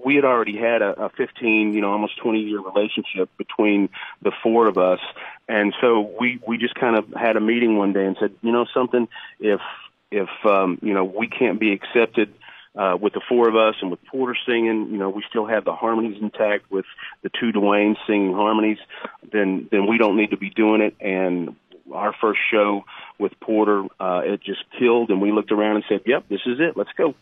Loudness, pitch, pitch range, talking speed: -21 LUFS, 105 Hz, 100-115 Hz, 215 wpm